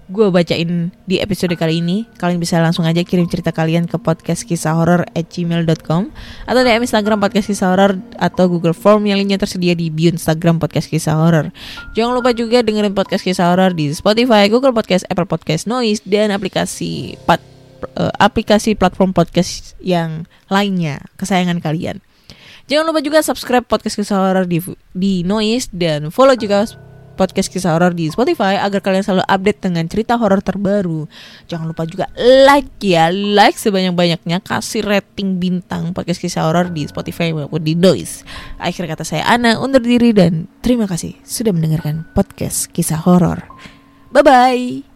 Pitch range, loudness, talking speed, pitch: 170-210 Hz, -15 LUFS, 165 wpm, 185 Hz